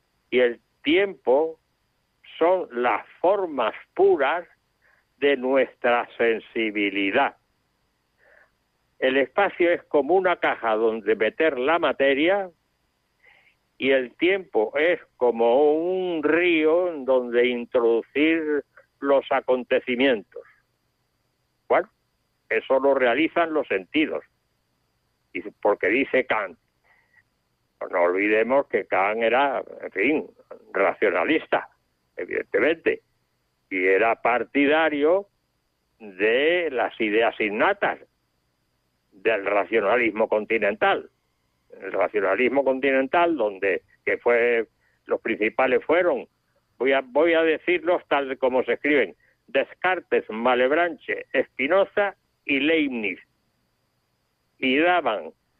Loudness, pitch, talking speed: -23 LUFS, 155 Hz, 90 wpm